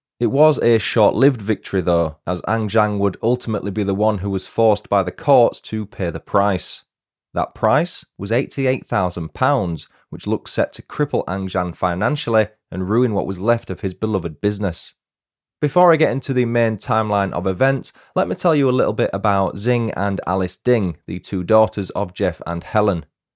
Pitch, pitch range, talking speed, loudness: 105 Hz, 95-120 Hz, 190 wpm, -19 LUFS